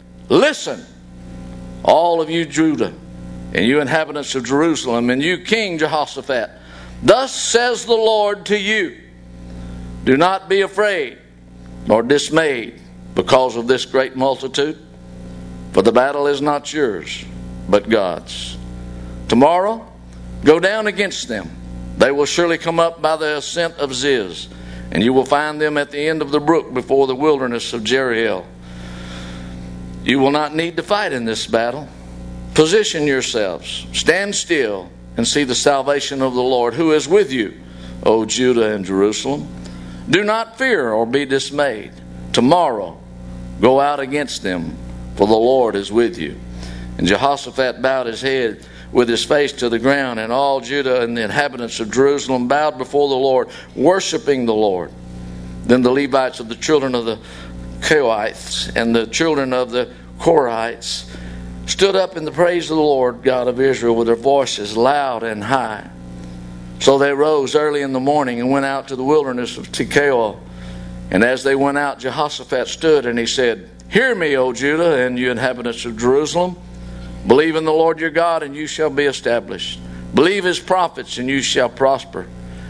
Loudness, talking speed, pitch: -17 LUFS, 165 wpm, 125 Hz